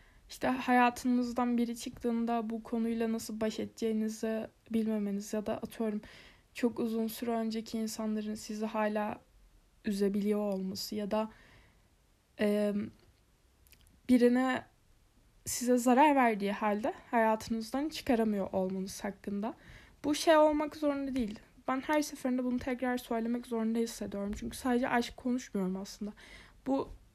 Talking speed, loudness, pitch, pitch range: 115 wpm, -33 LUFS, 225 Hz, 210-250 Hz